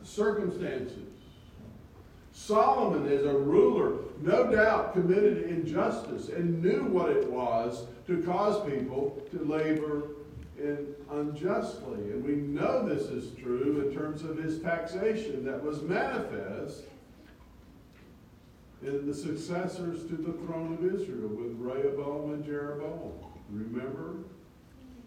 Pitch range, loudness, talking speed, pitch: 140-180 Hz, -31 LUFS, 115 wpm, 150 Hz